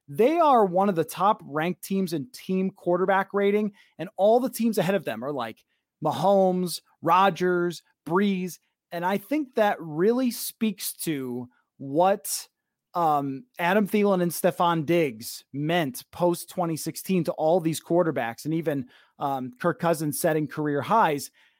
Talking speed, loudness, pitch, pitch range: 145 wpm, -25 LUFS, 175 Hz, 155-195 Hz